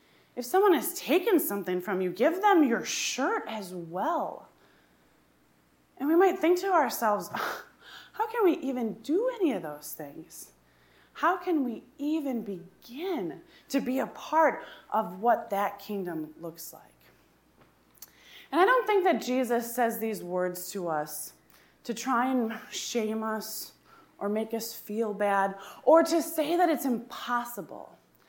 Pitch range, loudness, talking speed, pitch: 200-325 Hz, -28 LUFS, 150 wpm, 240 Hz